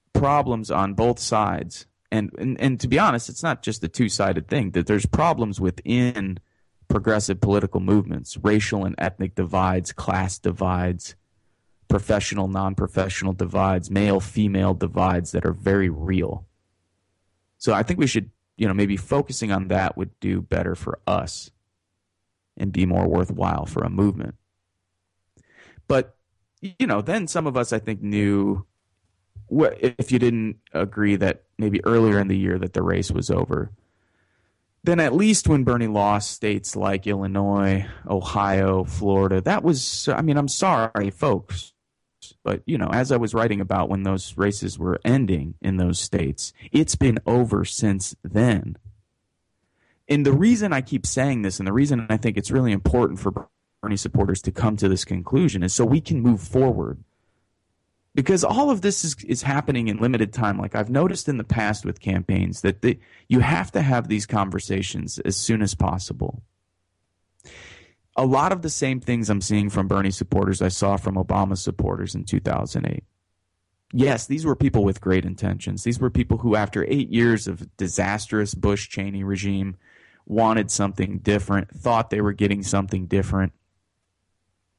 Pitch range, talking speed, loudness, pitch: 95-115 Hz, 165 wpm, -22 LUFS, 100 Hz